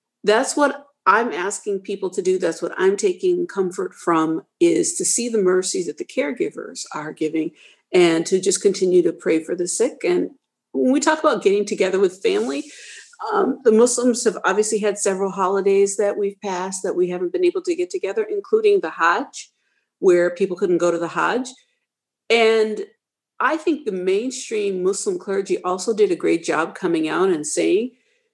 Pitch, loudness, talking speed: 220 Hz, -20 LUFS, 180 wpm